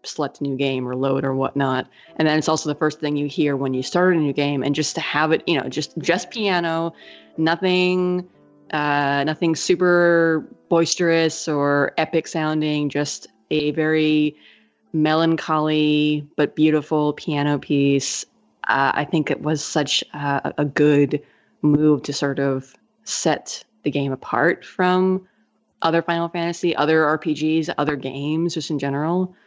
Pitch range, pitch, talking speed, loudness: 145-165 Hz, 155 Hz, 155 wpm, -21 LUFS